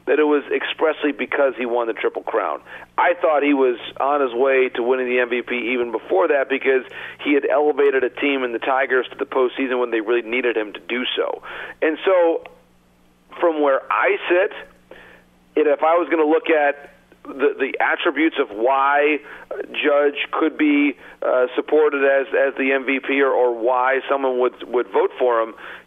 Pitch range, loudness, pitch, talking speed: 125-155 Hz, -19 LUFS, 135 Hz, 185 wpm